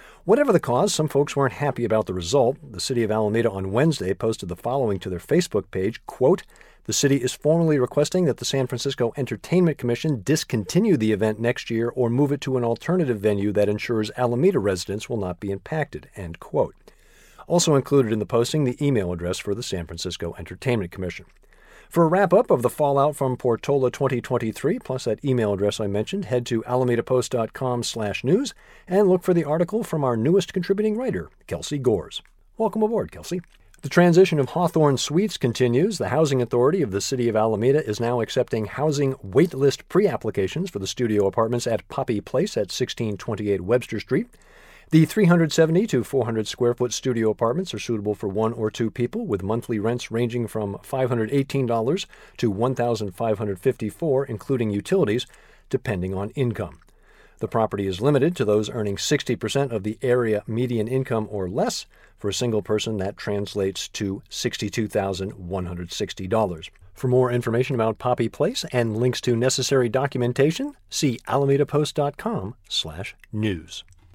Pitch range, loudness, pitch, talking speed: 105-140 Hz, -23 LUFS, 120 Hz, 160 wpm